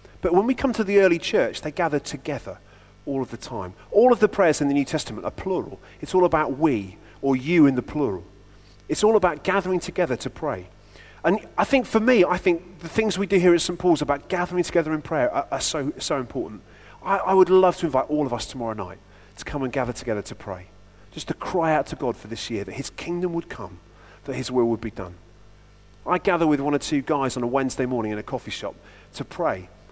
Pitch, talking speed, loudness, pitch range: 140 Hz, 245 wpm, -23 LUFS, 105-175 Hz